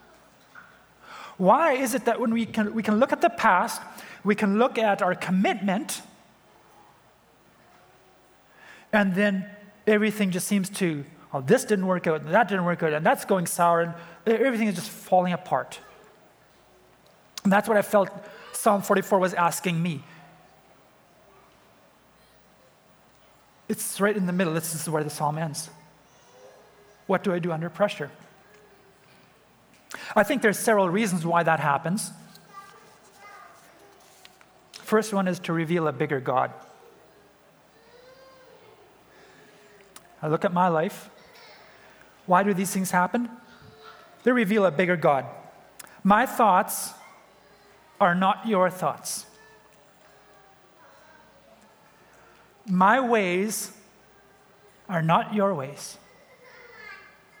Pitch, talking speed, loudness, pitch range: 200 Hz, 120 wpm, -24 LUFS, 180-220 Hz